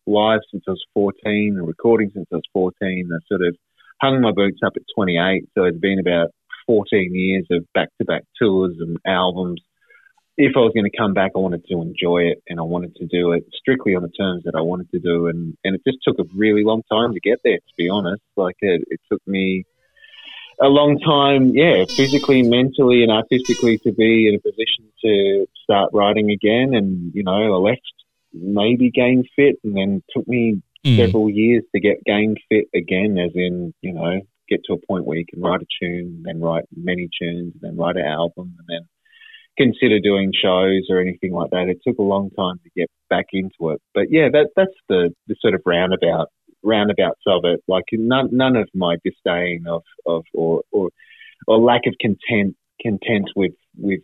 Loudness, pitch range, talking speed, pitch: -18 LUFS, 90-115 Hz, 205 wpm, 100 Hz